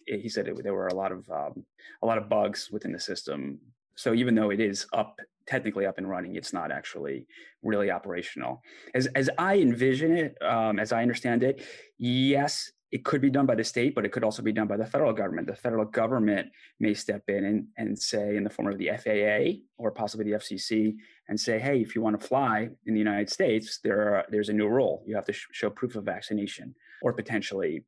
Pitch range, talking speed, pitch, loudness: 105-120 Hz, 230 wpm, 110 Hz, -28 LUFS